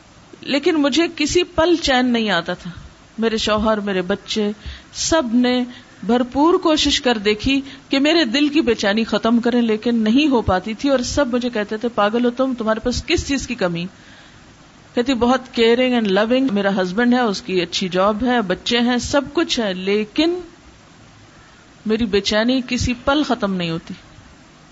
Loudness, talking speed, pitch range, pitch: -18 LUFS, 170 wpm, 210-275 Hz, 240 Hz